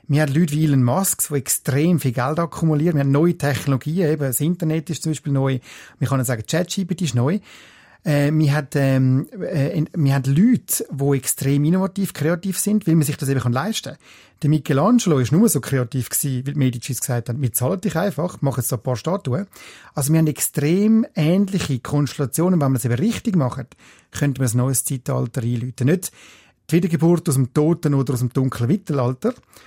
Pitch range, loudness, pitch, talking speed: 130-170 Hz, -20 LUFS, 145 Hz, 200 wpm